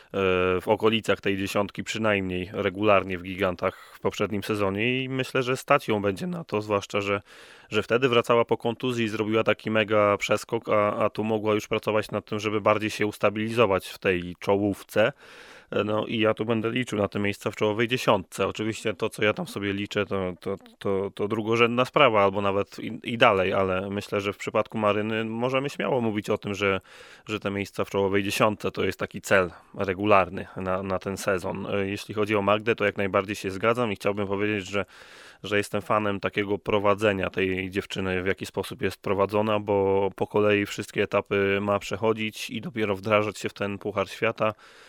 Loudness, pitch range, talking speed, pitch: -26 LUFS, 100-110 Hz, 190 wpm, 105 Hz